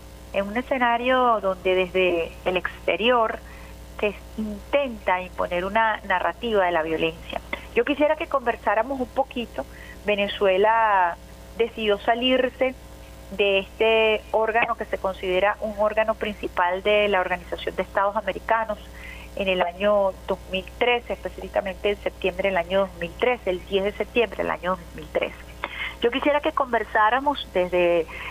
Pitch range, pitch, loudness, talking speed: 185-230 Hz, 205 Hz, -23 LUFS, 130 wpm